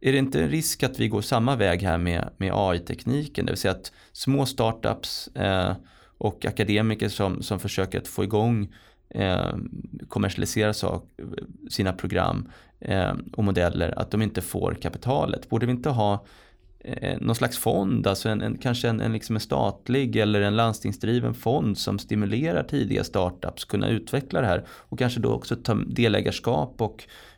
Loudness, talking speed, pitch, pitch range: -26 LUFS, 170 wpm, 105 Hz, 95-120 Hz